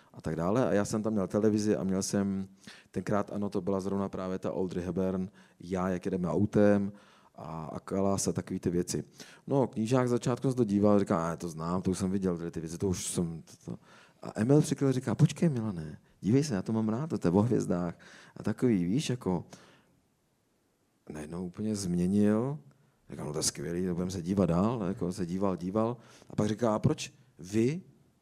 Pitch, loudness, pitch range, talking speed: 100 Hz, -31 LUFS, 95-110 Hz, 215 wpm